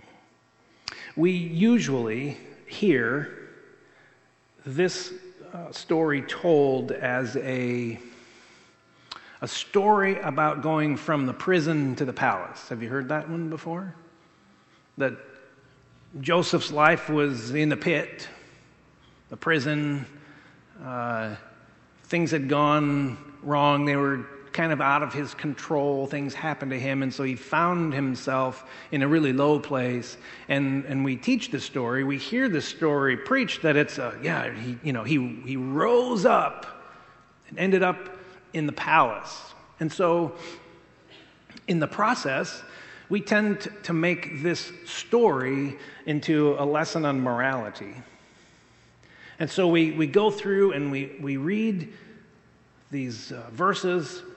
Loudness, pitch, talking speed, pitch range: -25 LUFS, 150 Hz, 130 wpm, 135-170 Hz